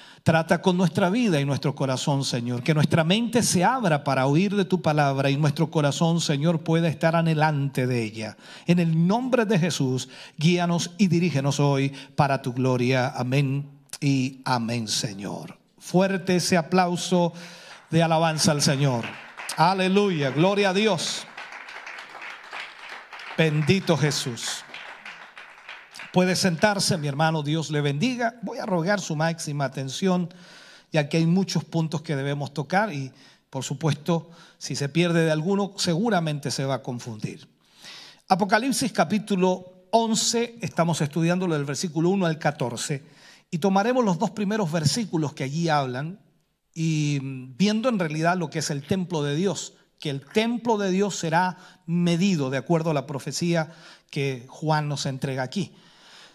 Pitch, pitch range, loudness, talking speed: 165 Hz, 140-185 Hz, -24 LUFS, 145 wpm